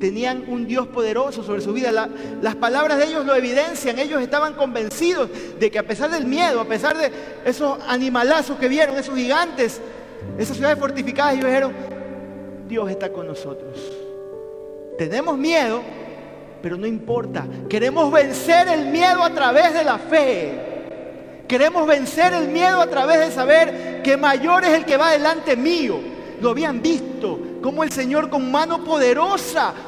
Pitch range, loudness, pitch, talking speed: 245-315 Hz, -19 LUFS, 280 Hz, 160 wpm